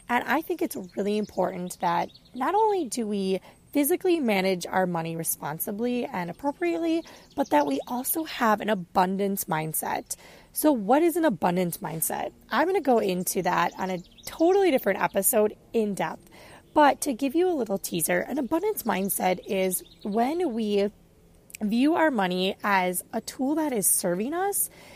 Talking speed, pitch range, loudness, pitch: 160 wpm, 185-295 Hz, -26 LUFS, 215 Hz